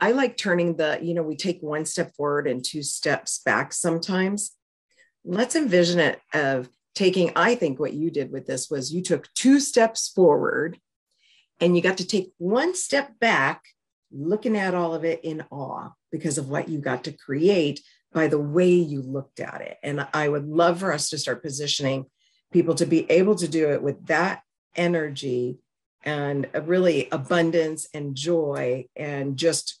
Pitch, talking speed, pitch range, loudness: 165 Hz, 180 wpm, 145-180 Hz, -24 LUFS